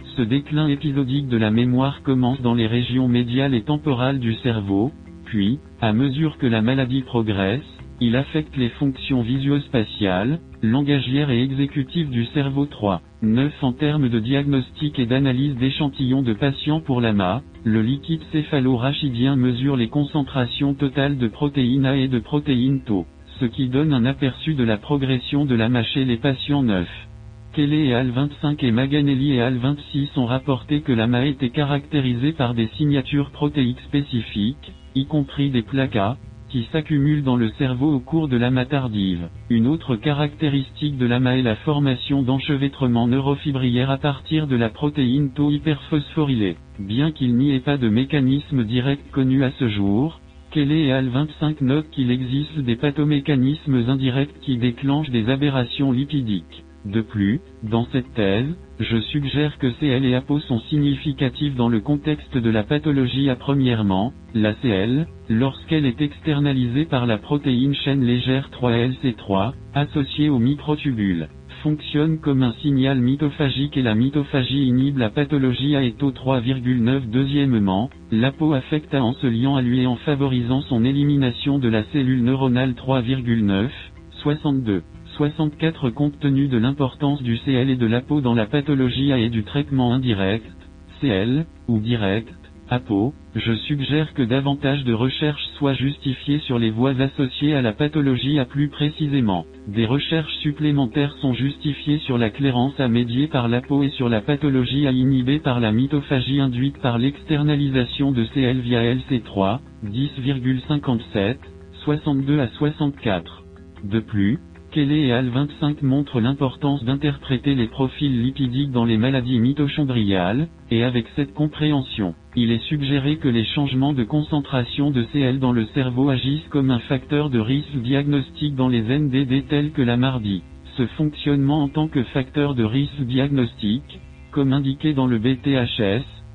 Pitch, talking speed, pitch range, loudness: 130 Hz, 155 wpm, 120-145 Hz, -21 LUFS